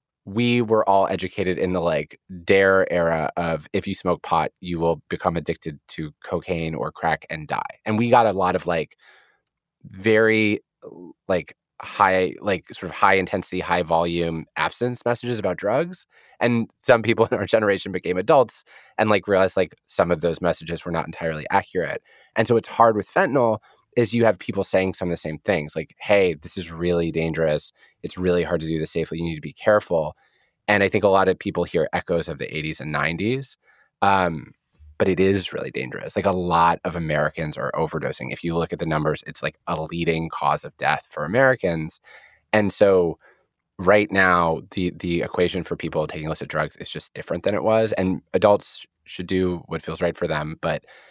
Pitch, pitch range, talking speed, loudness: 90 Hz, 85-100 Hz, 200 wpm, -22 LUFS